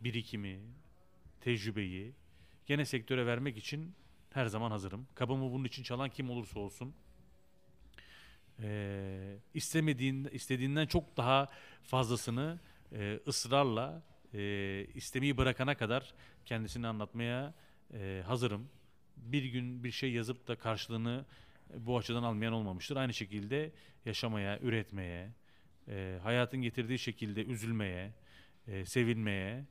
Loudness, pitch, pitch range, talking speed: -37 LUFS, 120 Hz, 105-130 Hz, 110 wpm